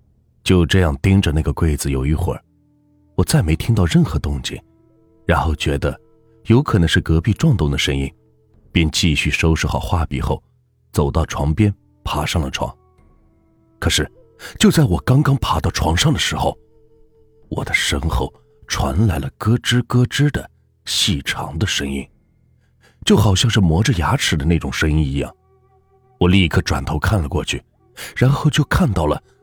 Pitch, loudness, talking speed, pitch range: 90 Hz, -18 LUFS, 235 characters per minute, 75-110 Hz